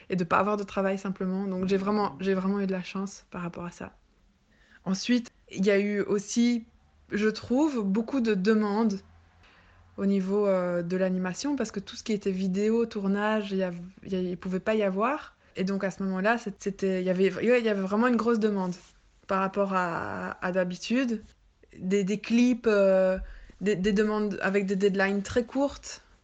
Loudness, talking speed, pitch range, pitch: -28 LUFS, 185 wpm, 190-215 Hz, 200 Hz